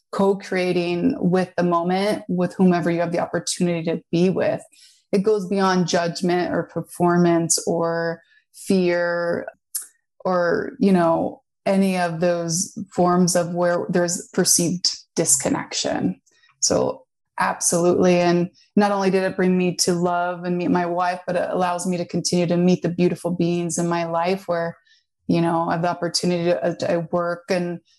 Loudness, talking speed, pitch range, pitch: -21 LUFS, 160 wpm, 175-185 Hz, 175 Hz